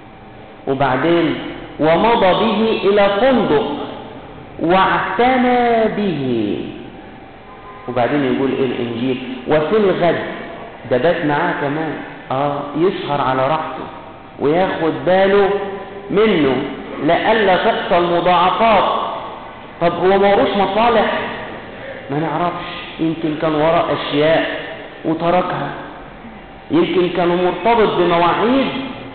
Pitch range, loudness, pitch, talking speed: 145-200 Hz, -16 LUFS, 175 Hz, 80 wpm